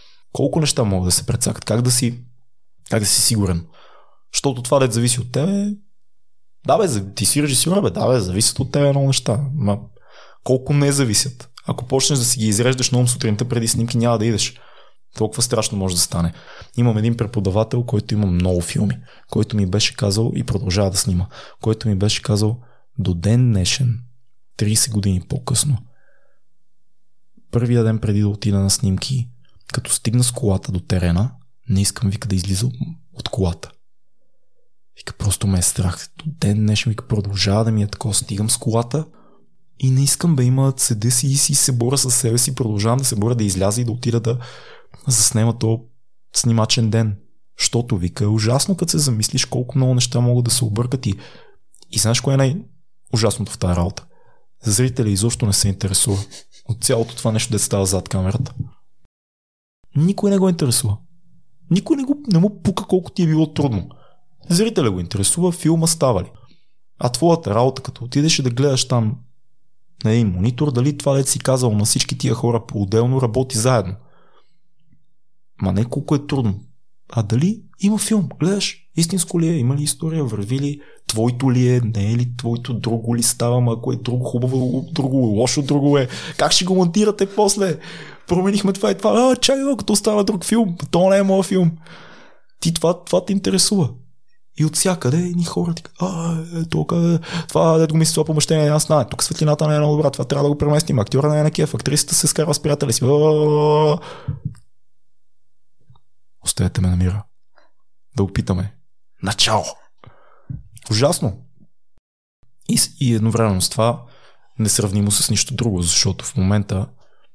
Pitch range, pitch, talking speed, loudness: 110-150 Hz, 125 Hz, 175 wpm, -18 LUFS